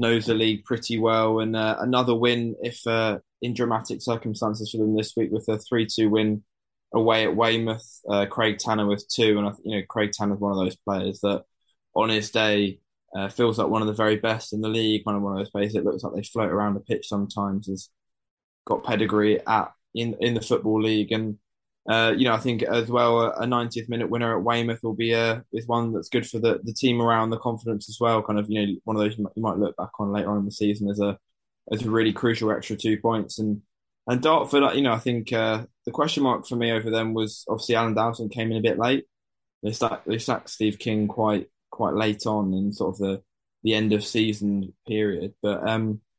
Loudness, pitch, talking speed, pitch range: -25 LUFS, 110 Hz, 235 wpm, 105-115 Hz